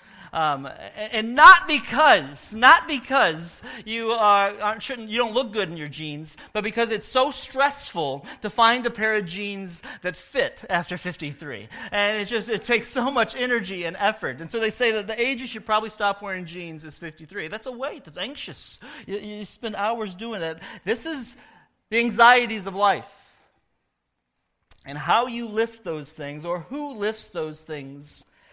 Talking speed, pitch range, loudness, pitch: 180 wpm, 180-240 Hz, -22 LUFS, 215 Hz